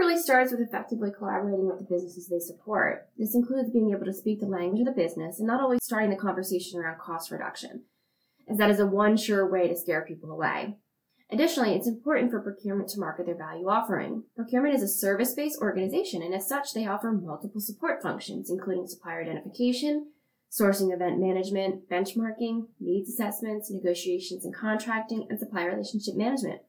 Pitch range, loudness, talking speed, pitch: 185-230 Hz, -28 LUFS, 180 wpm, 205 Hz